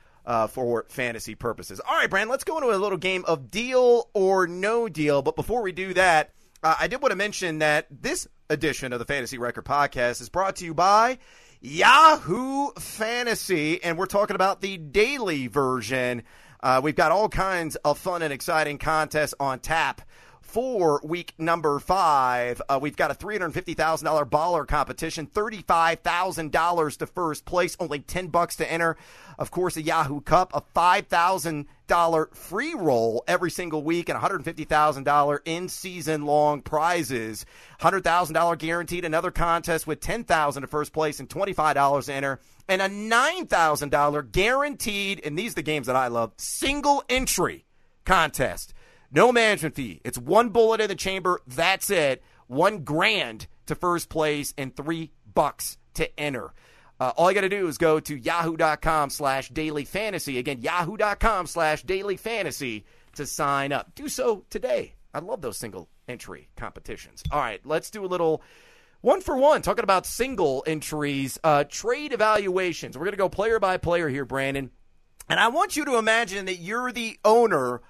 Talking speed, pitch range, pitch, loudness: 165 wpm, 145-195 Hz, 165 Hz, -24 LUFS